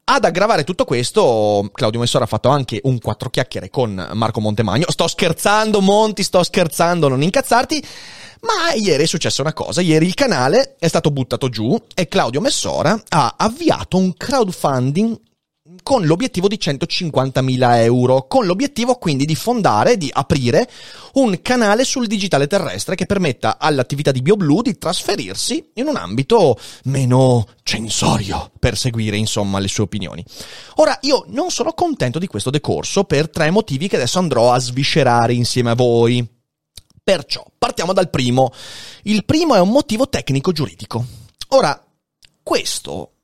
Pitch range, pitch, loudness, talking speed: 125-200 Hz, 150 Hz, -17 LUFS, 150 wpm